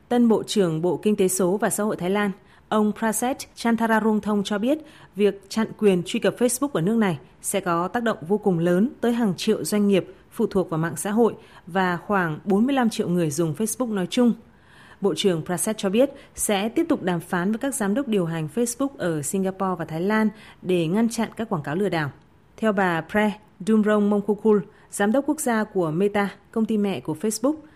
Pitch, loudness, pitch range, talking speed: 205 Hz, -23 LUFS, 185-220 Hz, 215 wpm